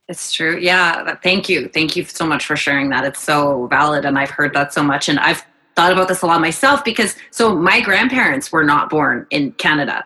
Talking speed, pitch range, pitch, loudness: 225 wpm, 150-185 Hz, 170 Hz, -15 LUFS